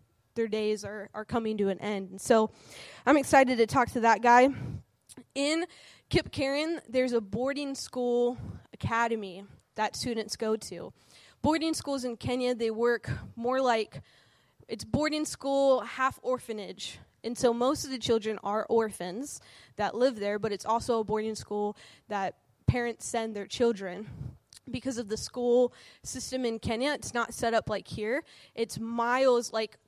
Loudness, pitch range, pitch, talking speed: -29 LUFS, 215-255 Hz, 235 Hz, 160 wpm